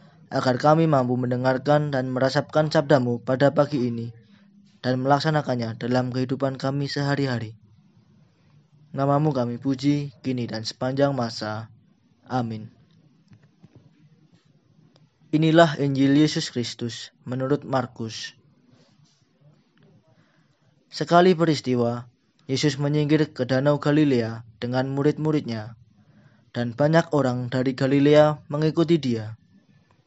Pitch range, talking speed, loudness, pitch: 125-150 Hz, 90 wpm, -23 LUFS, 135 Hz